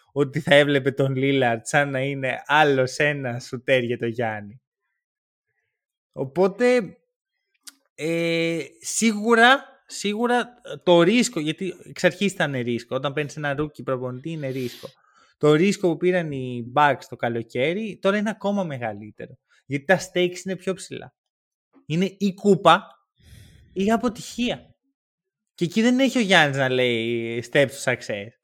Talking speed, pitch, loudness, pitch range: 140 wpm, 155 Hz, -22 LUFS, 130-195 Hz